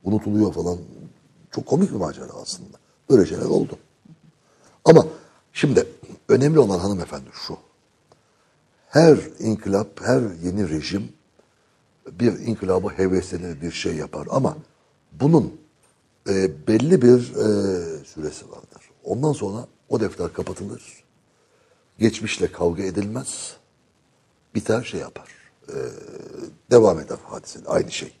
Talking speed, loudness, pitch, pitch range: 110 wpm, -21 LUFS, 100 Hz, 95-115 Hz